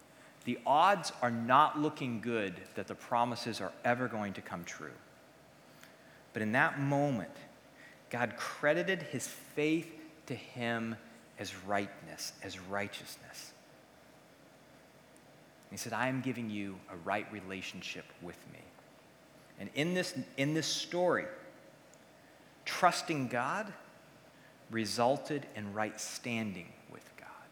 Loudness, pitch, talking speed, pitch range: -35 LUFS, 120 Hz, 115 wpm, 105-145 Hz